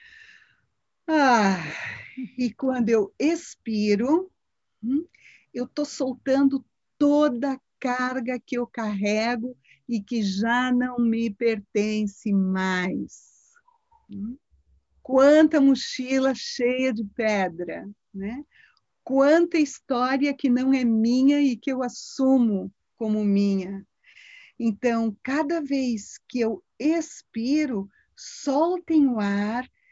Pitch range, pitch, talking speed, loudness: 220-280 Hz, 250 Hz, 95 wpm, -24 LUFS